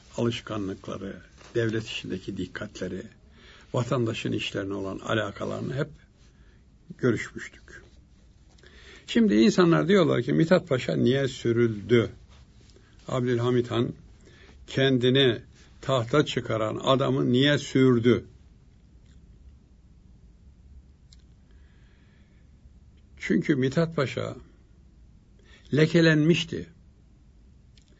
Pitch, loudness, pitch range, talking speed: 120 Hz, -25 LUFS, 90-135 Hz, 65 wpm